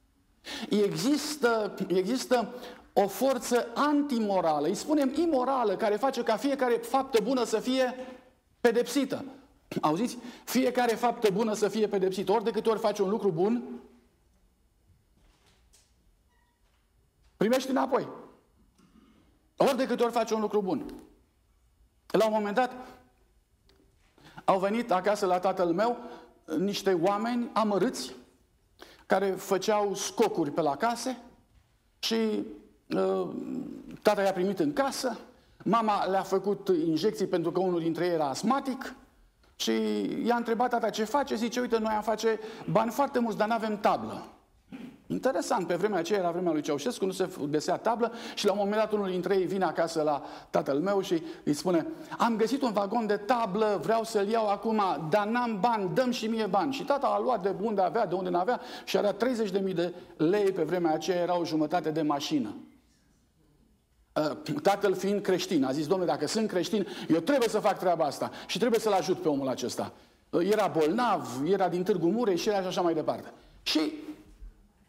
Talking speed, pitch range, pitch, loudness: 160 wpm, 185-245 Hz, 215 Hz, -29 LUFS